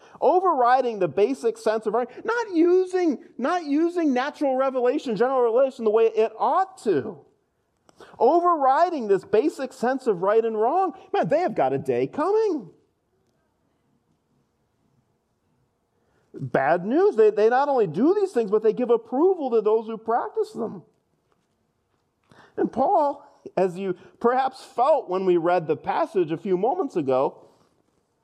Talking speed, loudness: 140 wpm, -23 LUFS